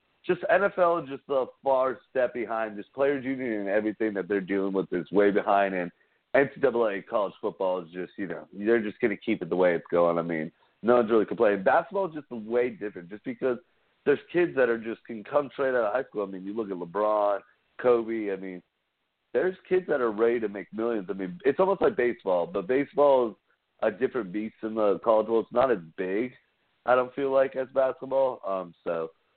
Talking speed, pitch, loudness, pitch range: 220 wpm, 115 Hz, -27 LUFS, 100-130 Hz